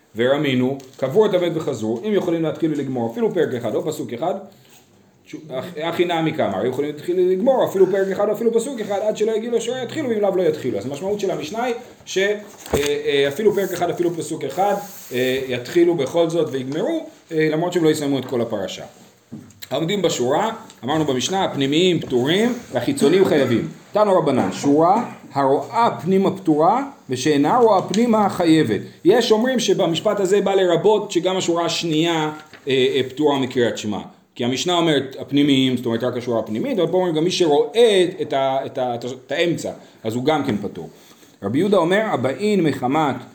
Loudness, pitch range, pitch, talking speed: -20 LUFS, 135-200 Hz, 170 Hz, 175 wpm